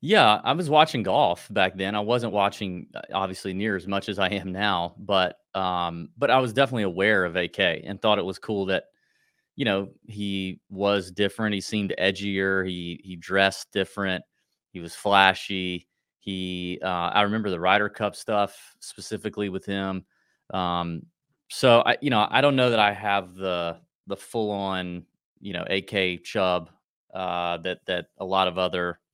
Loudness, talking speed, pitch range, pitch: -25 LUFS, 175 wpm, 90-105 Hz, 95 Hz